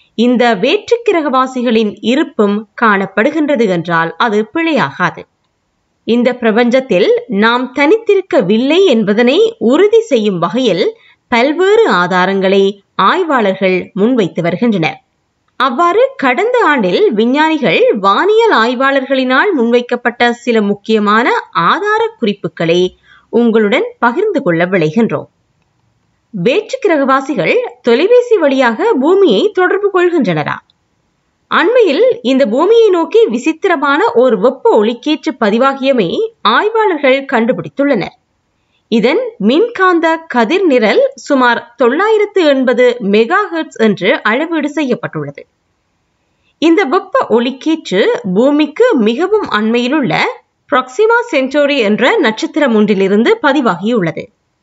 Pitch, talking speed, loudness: 270 Hz, 85 wpm, -11 LUFS